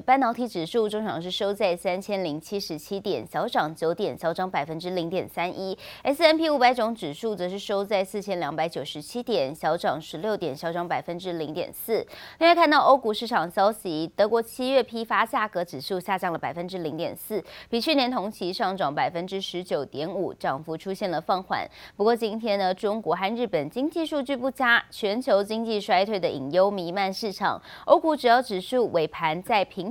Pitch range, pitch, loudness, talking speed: 175-235 Hz, 200 Hz, -26 LUFS, 305 characters per minute